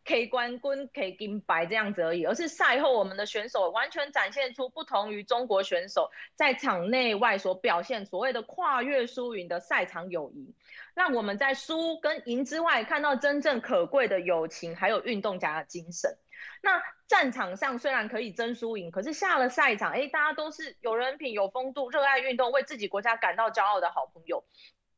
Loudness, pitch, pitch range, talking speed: -28 LUFS, 245 Hz, 200-280 Hz, 295 characters per minute